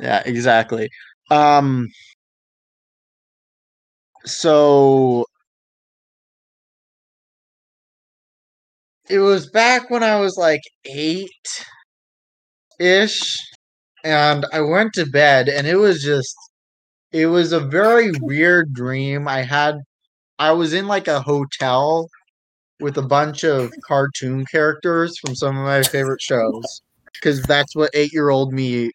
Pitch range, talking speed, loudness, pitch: 135-170 Hz, 110 wpm, -17 LUFS, 150 Hz